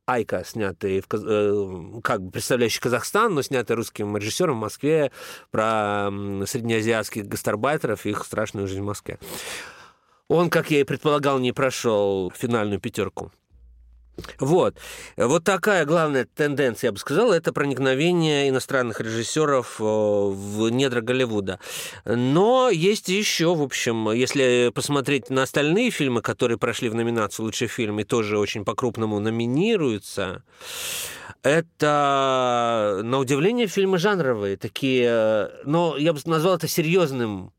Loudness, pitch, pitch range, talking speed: -23 LUFS, 125 Hz, 105-150 Hz, 125 wpm